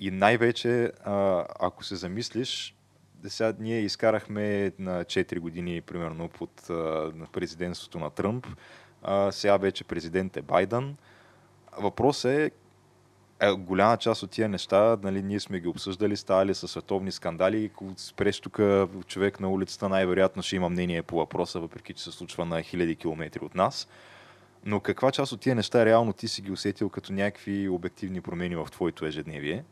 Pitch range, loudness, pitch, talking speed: 90-105 Hz, -28 LUFS, 95 Hz, 160 wpm